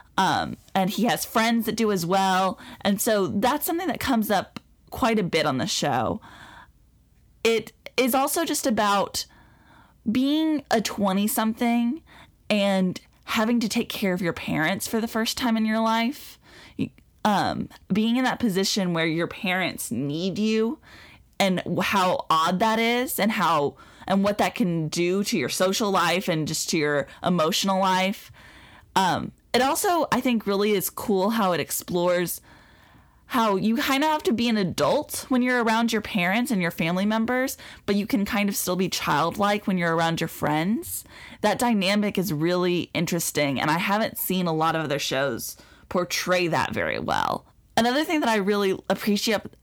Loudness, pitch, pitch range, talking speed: -24 LUFS, 205 Hz, 180-230 Hz, 175 wpm